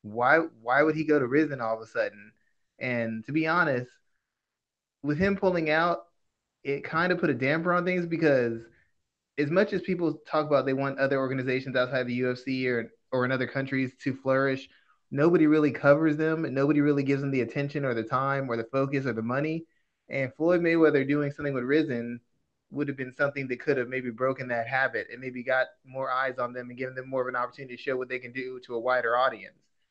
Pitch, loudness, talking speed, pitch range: 135 Hz, -27 LUFS, 220 wpm, 125-150 Hz